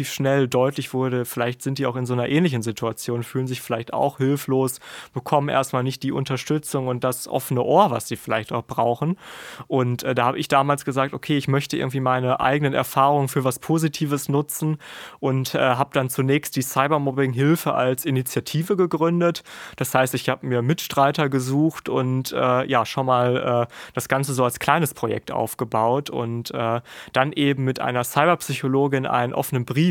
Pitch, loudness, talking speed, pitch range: 135 Hz, -22 LUFS, 180 wpm, 125-145 Hz